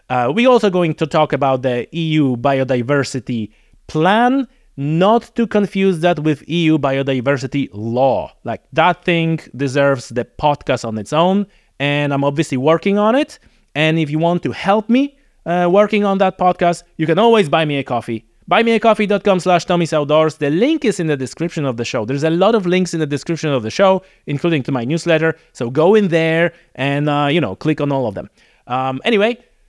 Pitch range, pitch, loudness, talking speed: 140-190 Hz, 160 Hz, -16 LUFS, 195 wpm